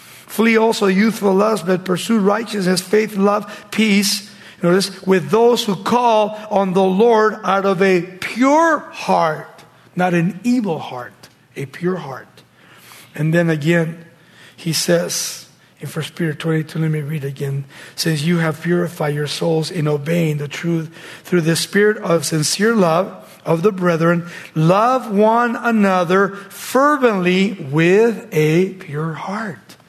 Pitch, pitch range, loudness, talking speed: 180 Hz, 160-205 Hz, -17 LUFS, 145 wpm